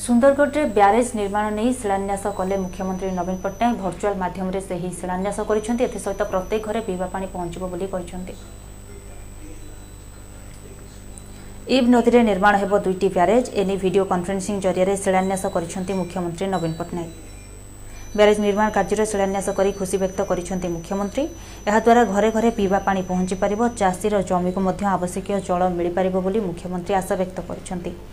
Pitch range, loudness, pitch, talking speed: 180-205 Hz, -21 LUFS, 190 Hz, 115 wpm